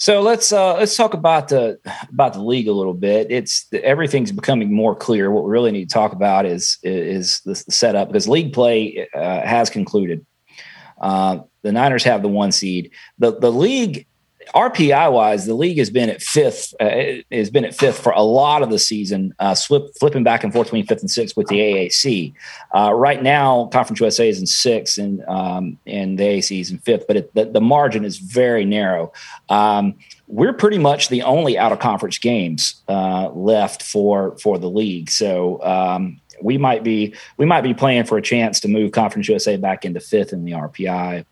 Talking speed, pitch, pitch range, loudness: 200 wpm, 110 Hz, 95-140 Hz, -17 LUFS